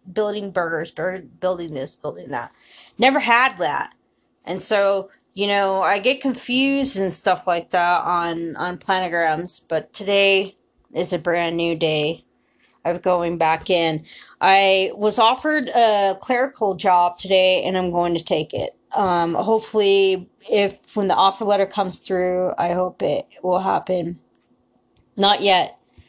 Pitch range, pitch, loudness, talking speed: 175-205 Hz, 185 Hz, -20 LUFS, 145 wpm